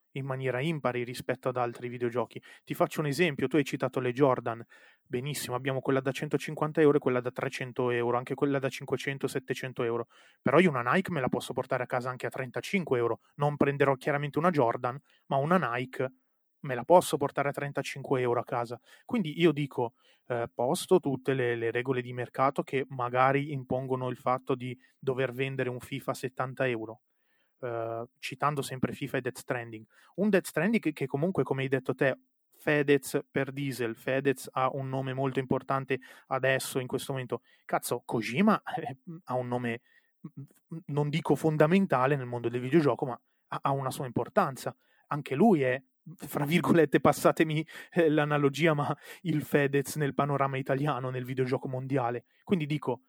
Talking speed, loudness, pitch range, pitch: 175 wpm, -30 LUFS, 125-150 Hz, 135 Hz